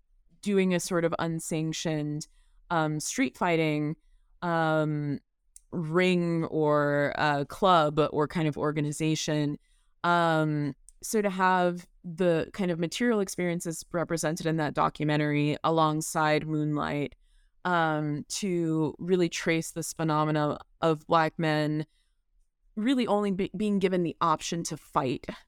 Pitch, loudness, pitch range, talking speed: 160 Hz, -28 LUFS, 150-175 Hz, 120 wpm